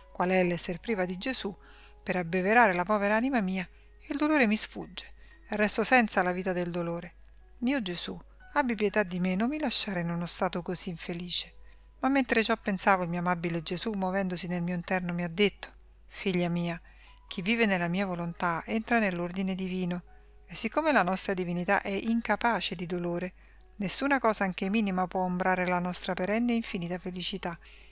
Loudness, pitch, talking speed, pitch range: -29 LUFS, 190 Hz, 180 wpm, 180-225 Hz